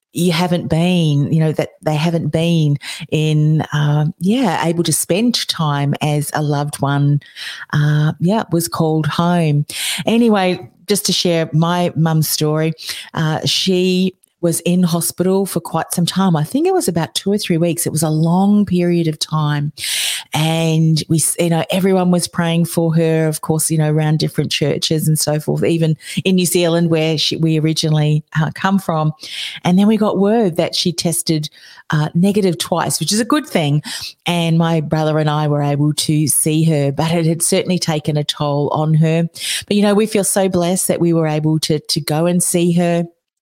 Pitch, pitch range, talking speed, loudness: 165 Hz, 155-180 Hz, 190 wpm, -16 LUFS